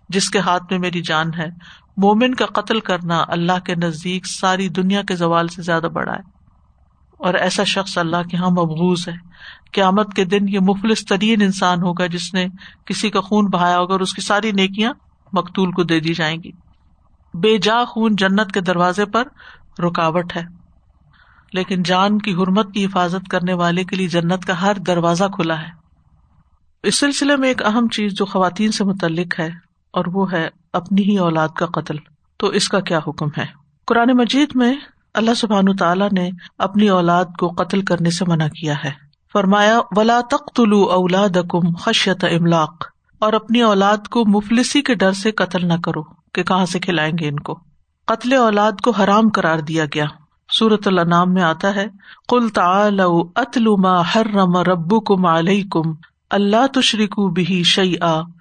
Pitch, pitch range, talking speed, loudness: 185 Hz, 170-210 Hz, 175 wpm, -17 LUFS